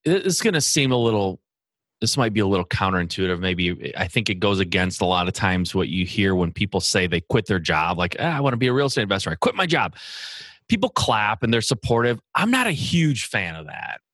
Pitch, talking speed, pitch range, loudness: 105 Hz, 245 wpm, 95-135 Hz, -21 LUFS